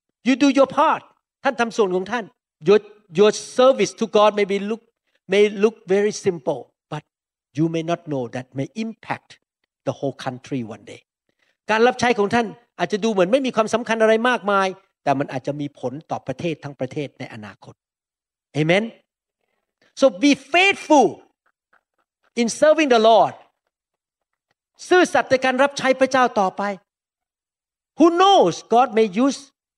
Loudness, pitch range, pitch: -19 LUFS, 160-255 Hz, 210 Hz